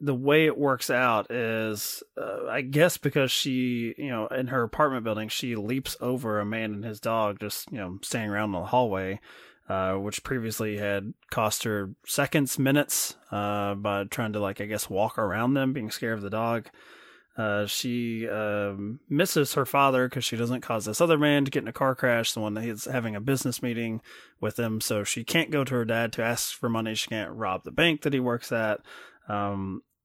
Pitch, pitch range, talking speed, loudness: 115 Hz, 105-130 Hz, 210 wpm, -27 LUFS